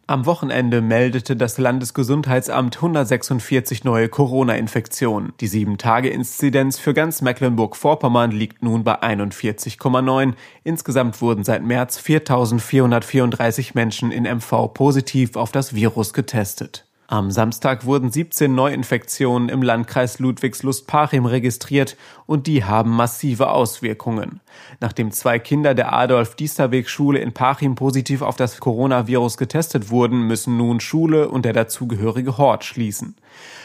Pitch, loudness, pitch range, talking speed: 125 Hz, -19 LUFS, 115-135 Hz, 115 wpm